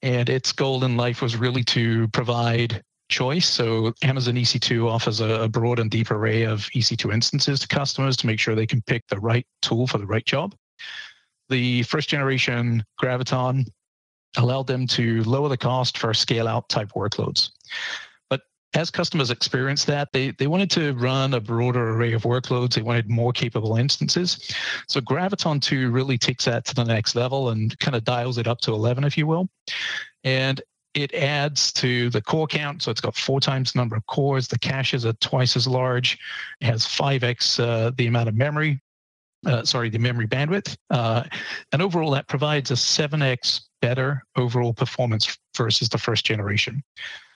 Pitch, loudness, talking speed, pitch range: 125 Hz, -22 LUFS, 180 wpm, 115-140 Hz